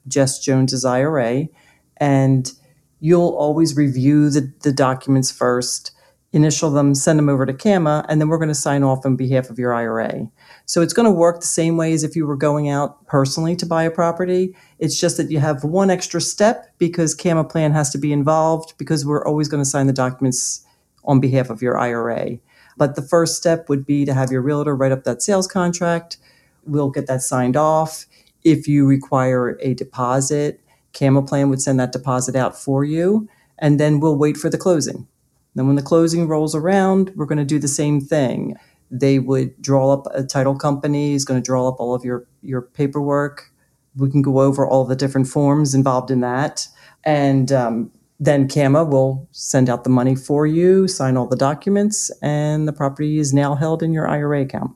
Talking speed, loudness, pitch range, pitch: 205 wpm, -18 LUFS, 135-155 Hz, 145 Hz